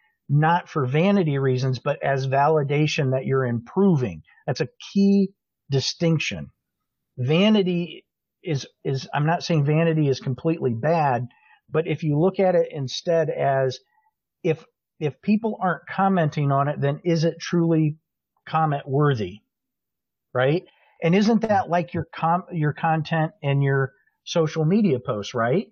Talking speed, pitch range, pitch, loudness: 140 wpm, 140-175 Hz, 160 Hz, -23 LUFS